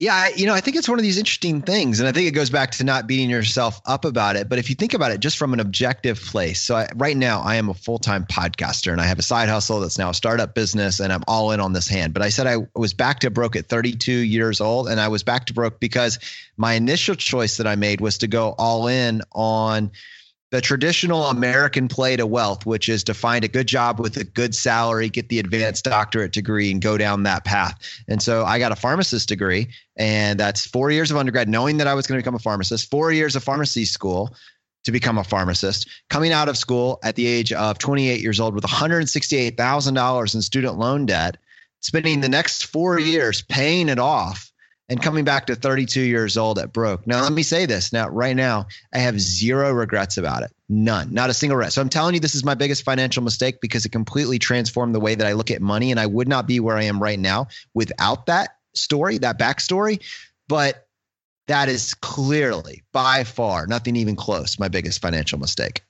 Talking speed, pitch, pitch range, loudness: 230 wpm, 120 Hz, 110-135 Hz, -20 LUFS